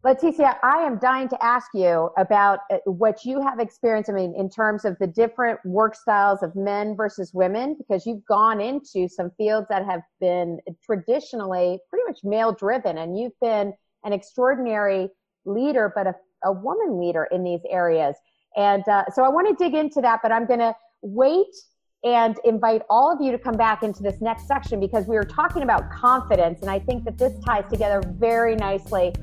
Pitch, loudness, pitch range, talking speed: 215 Hz, -22 LUFS, 195-245 Hz, 190 wpm